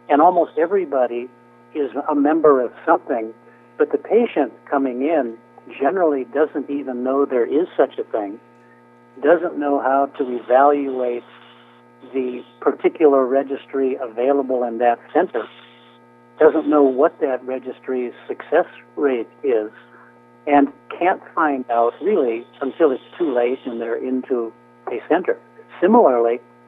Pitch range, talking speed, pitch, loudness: 95-145 Hz, 130 wpm, 130 Hz, -19 LUFS